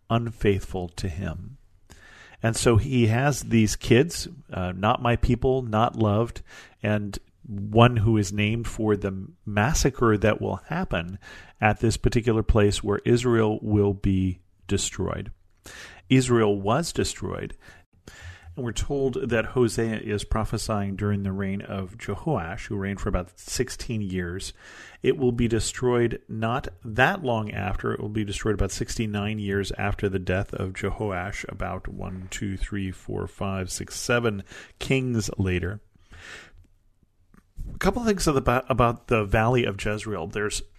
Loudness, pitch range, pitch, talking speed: -25 LUFS, 95-115 Hz, 105 Hz, 140 wpm